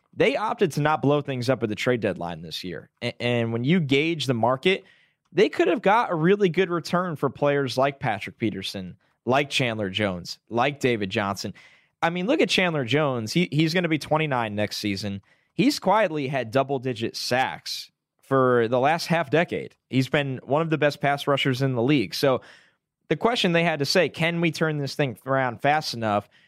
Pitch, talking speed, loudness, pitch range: 140 Hz, 200 wpm, -24 LUFS, 120-160 Hz